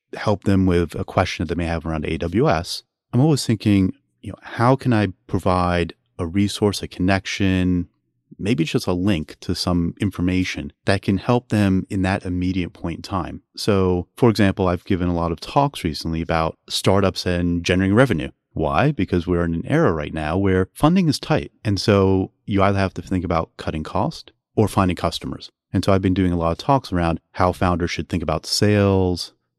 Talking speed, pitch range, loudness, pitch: 195 wpm, 85-100 Hz, -21 LUFS, 95 Hz